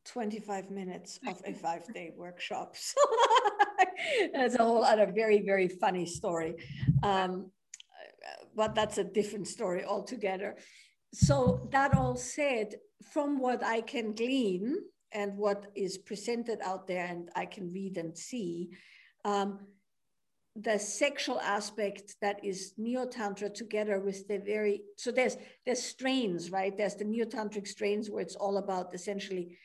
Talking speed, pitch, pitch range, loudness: 140 wpm, 205 Hz, 190-230 Hz, -32 LUFS